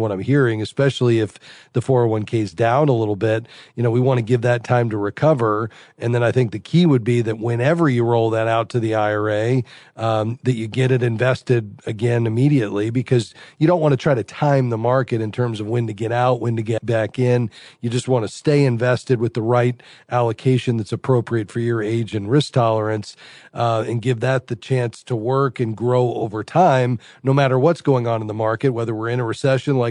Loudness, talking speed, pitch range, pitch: -19 LUFS, 225 wpm, 115-130 Hz, 120 Hz